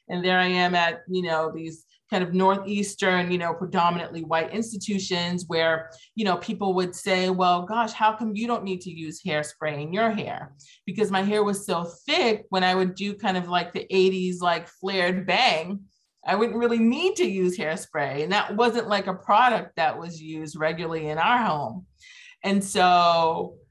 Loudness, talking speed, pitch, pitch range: -24 LUFS, 190 wpm, 185 Hz, 170-205 Hz